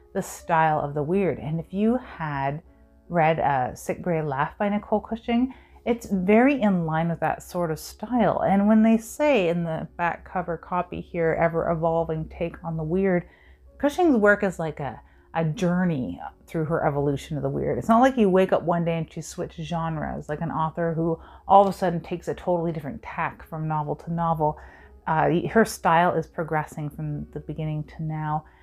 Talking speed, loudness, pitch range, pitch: 195 wpm, -24 LUFS, 155-195 Hz, 165 Hz